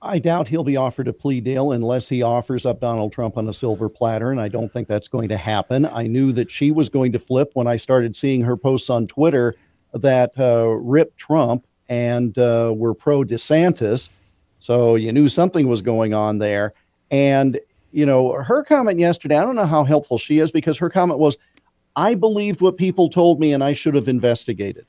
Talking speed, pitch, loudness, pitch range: 210 wpm, 130 Hz, -18 LUFS, 115-150 Hz